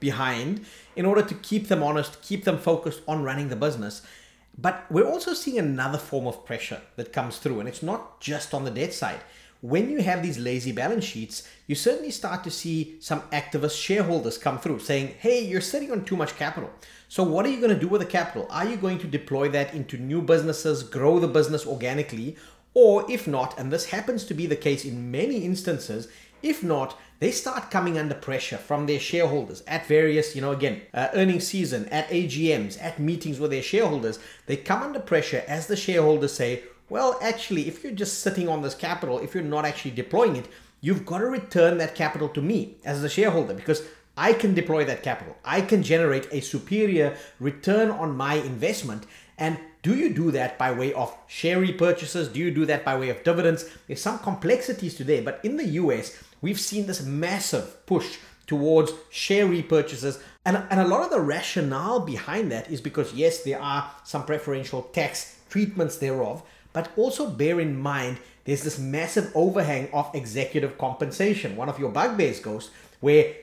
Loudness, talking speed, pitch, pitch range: -26 LUFS, 195 wpm, 160 Hz, 140-190 Hz